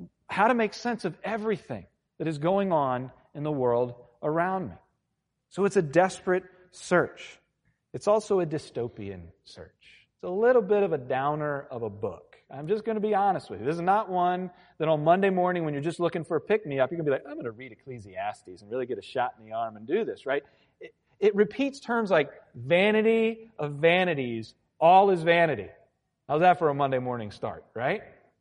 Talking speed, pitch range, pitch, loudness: 215 wpm, 145-210 Hz, 175 Hz, -27 LUFS